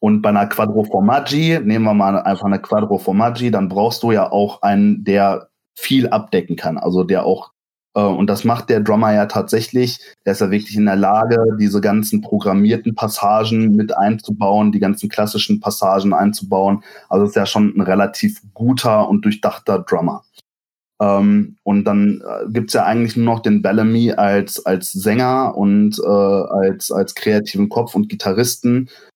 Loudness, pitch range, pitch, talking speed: -16 LUFS, 100-115 Hz, 105 Hz, 165 wpm